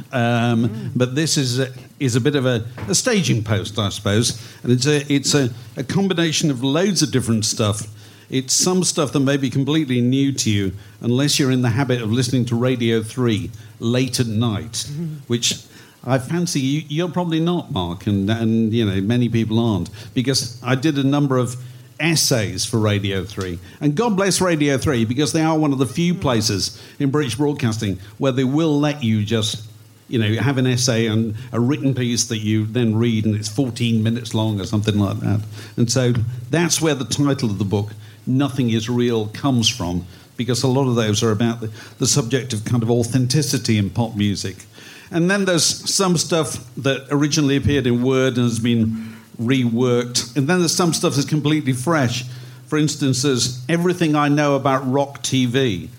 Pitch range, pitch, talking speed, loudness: 115-140 Hz, 125 Hz, 200 wpm, -19 LUFS